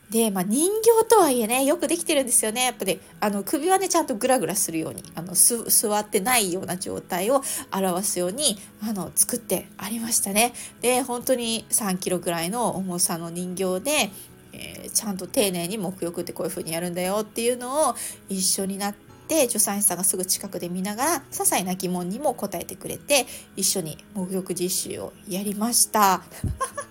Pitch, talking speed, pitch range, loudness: 205 Hz, 370 characters per minute, 180-245 Hz, -23 LUFS